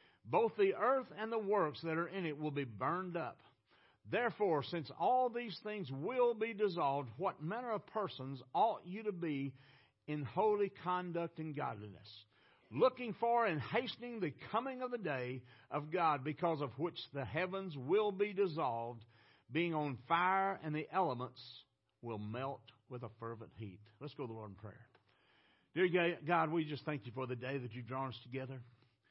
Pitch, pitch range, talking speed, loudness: 150 Hz, 125-195 Hz, 180 wpm, -38 LUFS